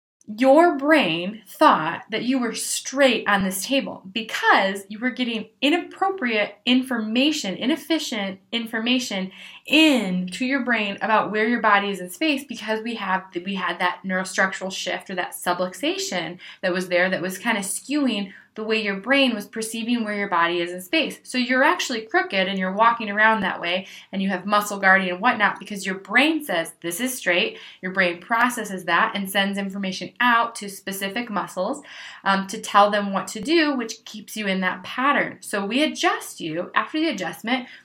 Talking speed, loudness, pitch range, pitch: 180 wpm, -22 LUFS, 190-255 Hz, 215 Hz